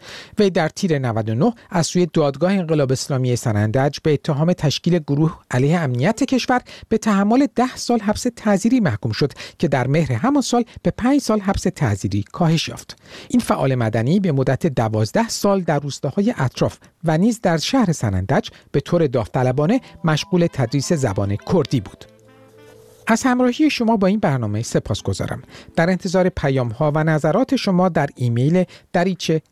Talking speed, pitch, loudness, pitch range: 160 wpm, 165 Hz, -19 LUFS, 130-205 Hz